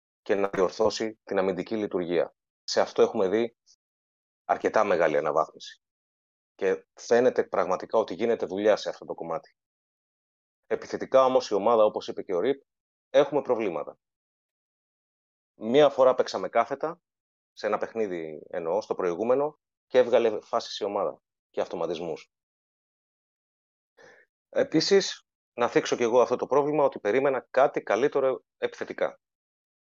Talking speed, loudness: 130 wpm, -26 LUFS